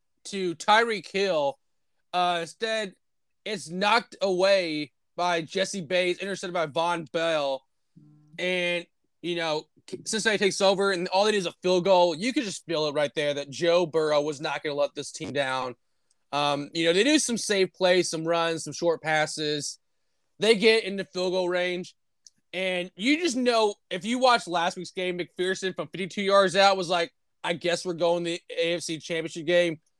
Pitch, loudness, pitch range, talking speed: 175 Hz, -26 LUFS, 160-195 Hz, 185 wpm